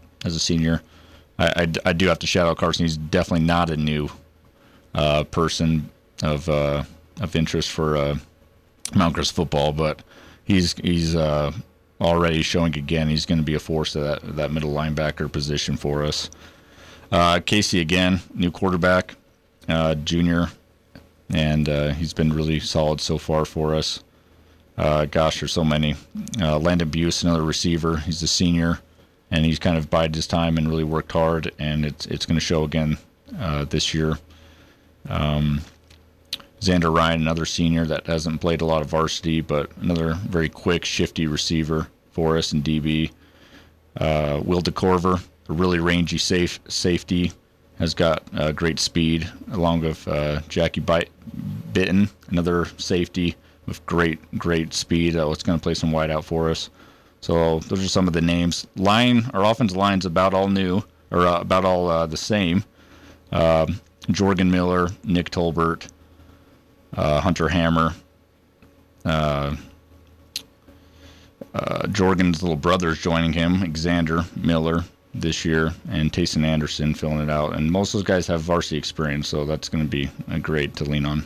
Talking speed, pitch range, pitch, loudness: 165 wpm, 80-90 Hz, 85 Hz, -22 LUFS